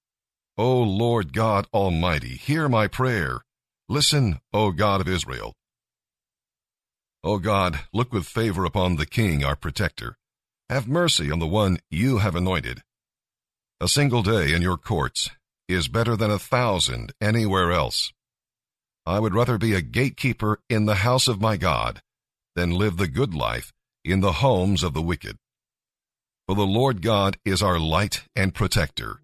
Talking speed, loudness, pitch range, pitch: 155 wpm, -23 LUFS, 90-115 Hz, 105 Hz